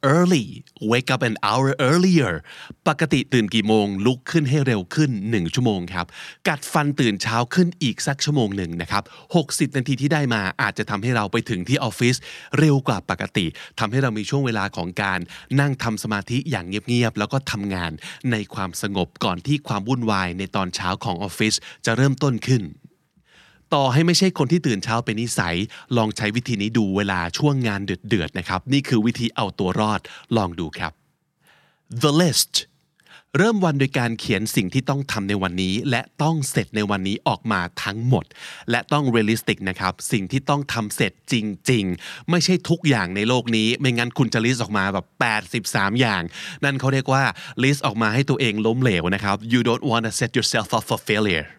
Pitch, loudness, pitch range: 115 Hz, -21 LUFS, 105-135 Hz